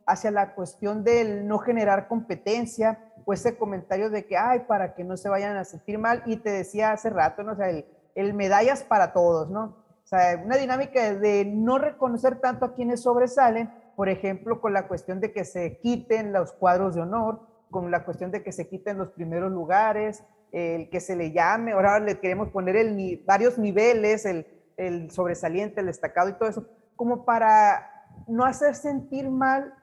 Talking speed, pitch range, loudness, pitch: 195 wpm, 185-230 Hz, -25 LUFS, 210 Hz